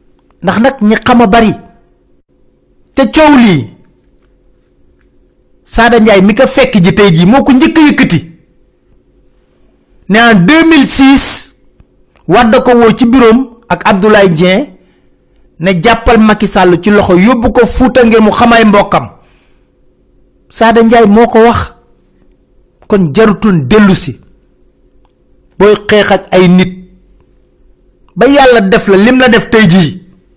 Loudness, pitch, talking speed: -6 LUFS, 195 Hz, 125 wpm